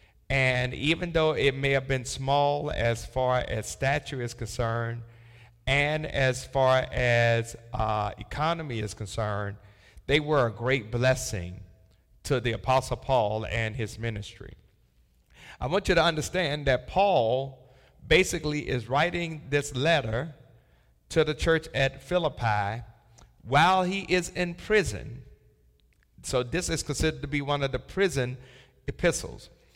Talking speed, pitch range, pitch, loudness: 135 wpm, 115-145 Hz, 130 Hz, -27 LUFS